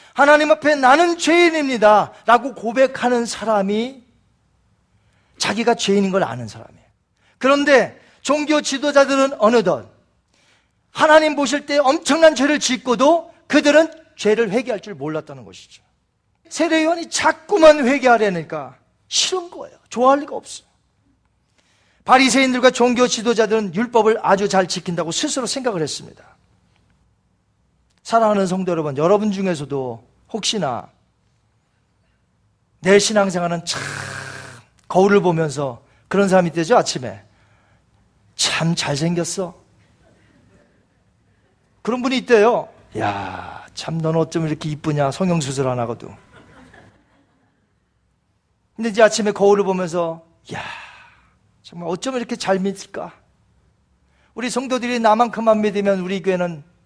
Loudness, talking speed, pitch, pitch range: -17 LUFS, 270 characters per minute, 210 Hz, 165-255 Hz